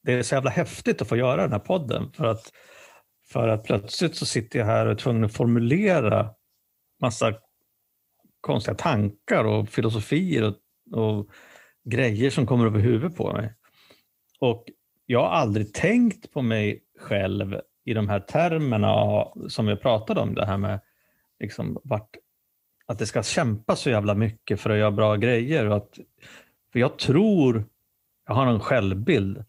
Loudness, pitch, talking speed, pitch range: -24 LUFS, 110 Hz, 165 wpm, 105-130 Hz